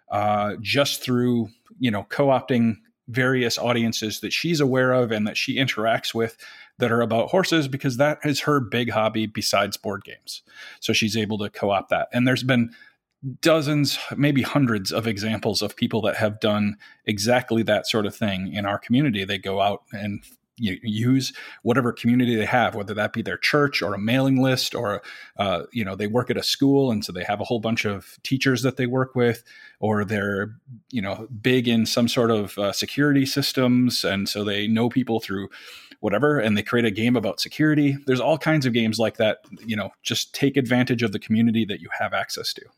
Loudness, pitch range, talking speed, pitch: -23 LUFS, 105-130 Hz, 200 wpm, 115 Hz